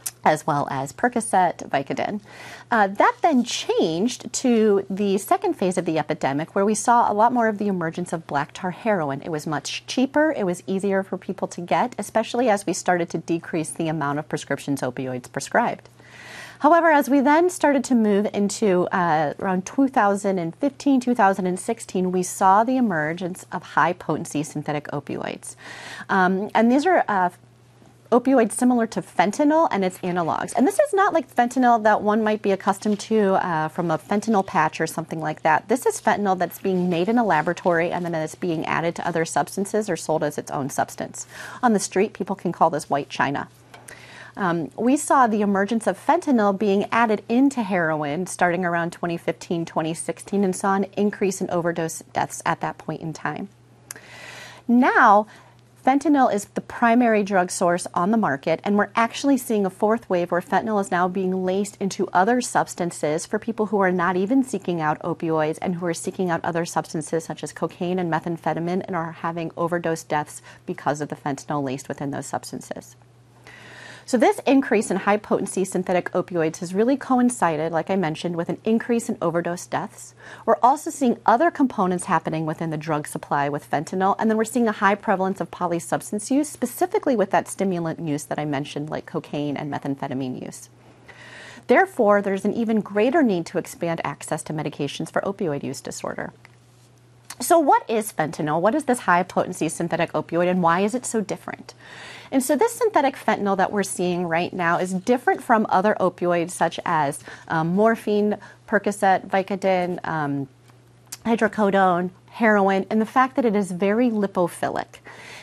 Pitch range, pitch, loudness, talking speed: 165-220 Hz, 185 Hz, -22 LUFS, 180 wpm